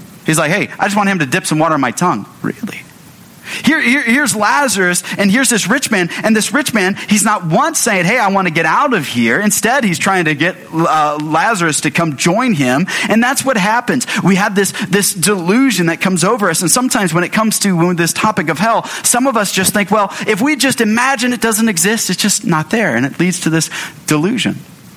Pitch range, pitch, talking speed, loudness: 175-225 Hz, 200 Hz, 235 wpm, -13 LUFS